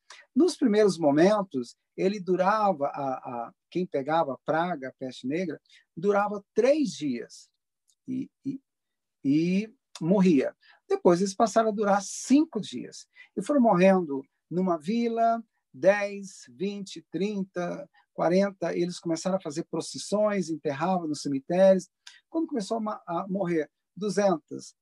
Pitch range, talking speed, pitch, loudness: 165-215 Hz, 125 wpm, 190 Hz, -27 LUFS